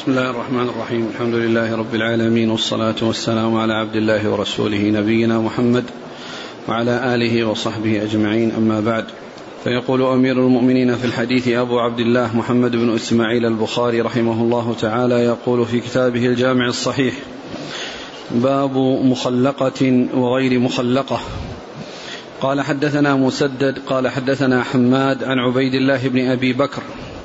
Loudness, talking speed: -18 LUFS, 130 wpm